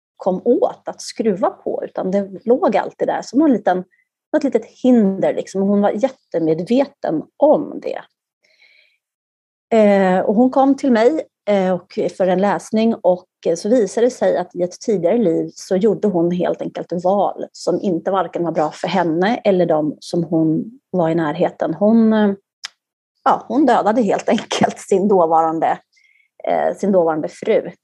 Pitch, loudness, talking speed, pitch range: 195 Hz, -17 LUFS, 150 wpm, 175-240 Hz